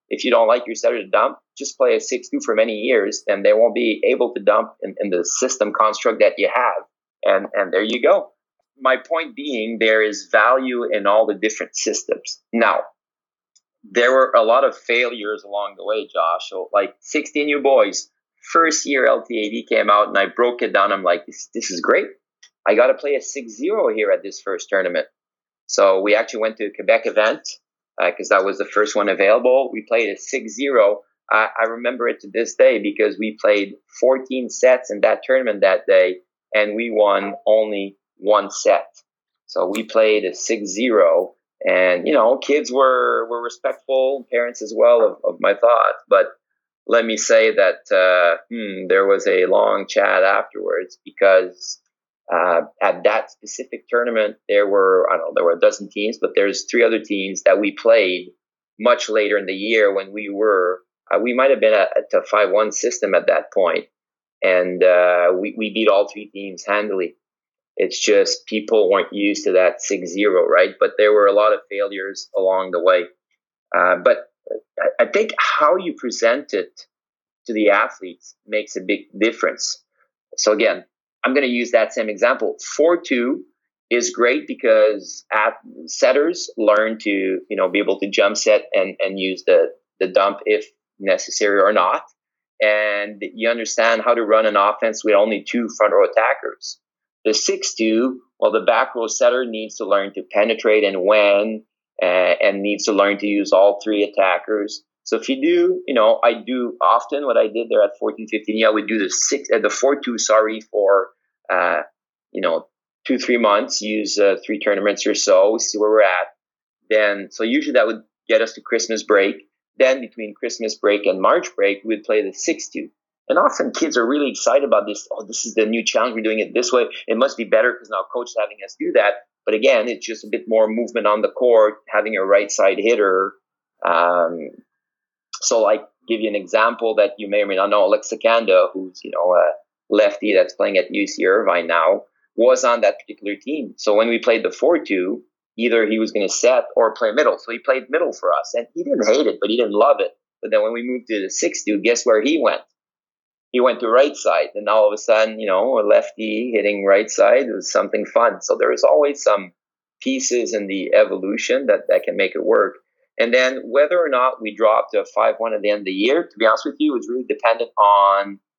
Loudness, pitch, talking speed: -18 LUFS, 130 Hz, 205 wpm